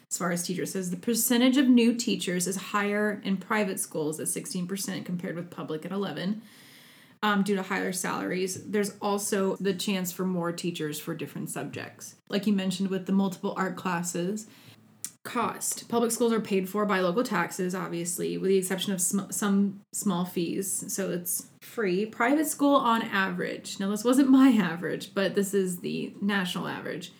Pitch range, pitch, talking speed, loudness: 180-210 Hz, 195 Hz, 180 wpm, -28 LUFS